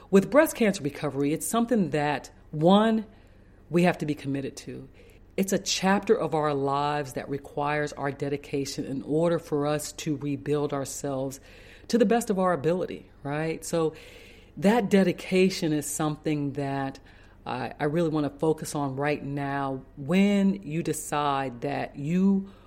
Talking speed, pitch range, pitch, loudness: 150 wpm, 140-175 Hz, 150 Hz, -27 LUFS